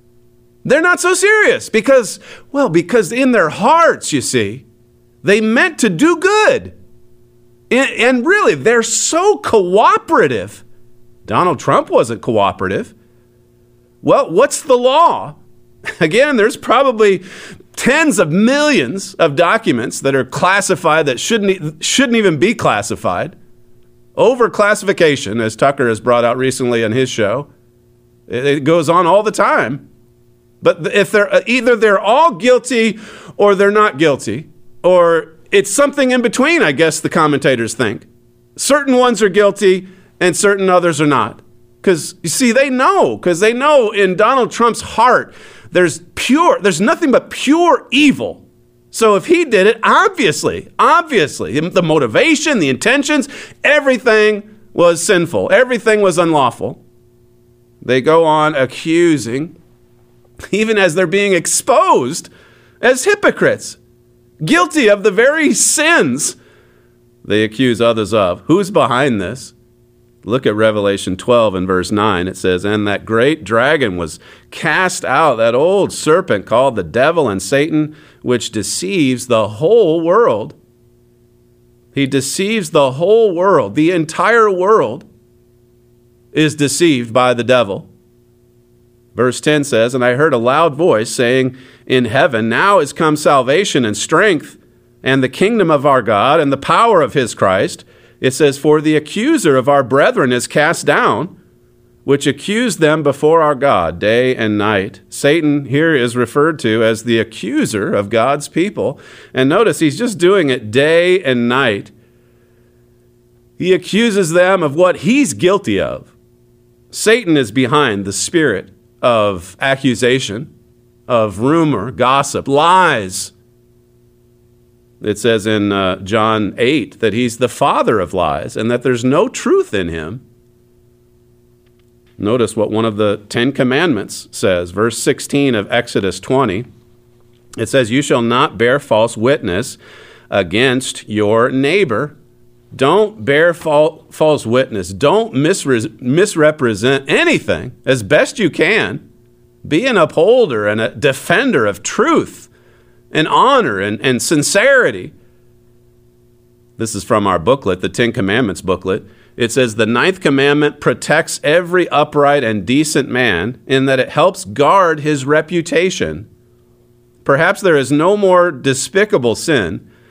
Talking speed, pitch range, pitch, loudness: 135 wpm, 120-190 Hz, 135 Hz, -13 LUFS